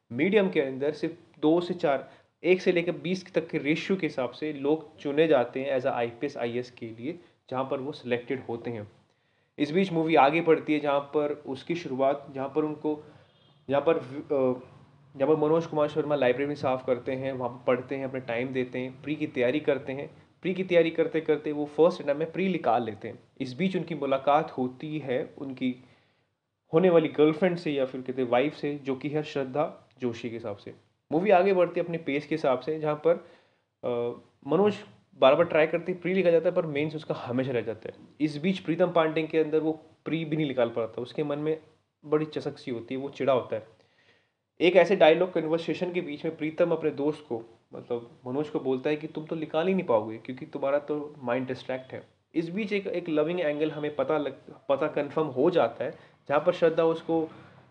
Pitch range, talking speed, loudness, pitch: 130-160 Hz, 215 wpm, -28 LUFS, 150 Hz